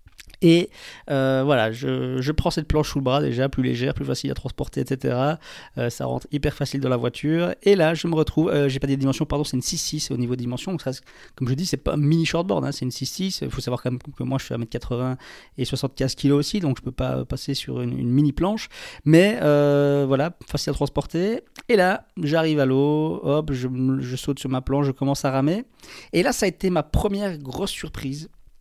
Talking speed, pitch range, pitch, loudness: 240 wpm, 130-155 Hz, 140 Hz, -23 LUFS